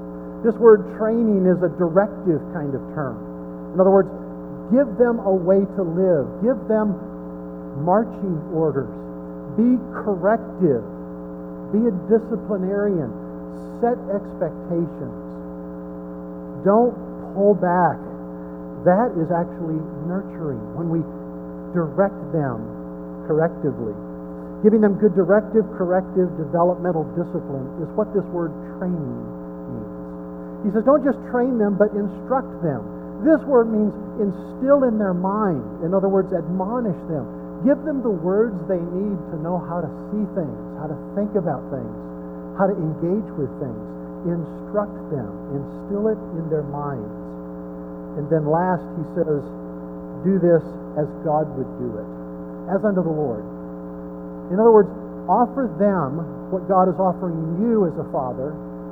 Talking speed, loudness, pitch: 135 wpm, -21 LUFS, 165 Hz